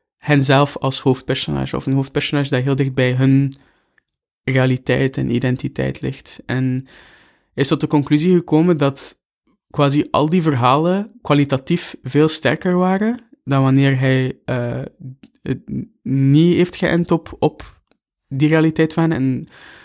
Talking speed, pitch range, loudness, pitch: 130 wpm, 130-160 Hz, -17 LUFS, 140 Hz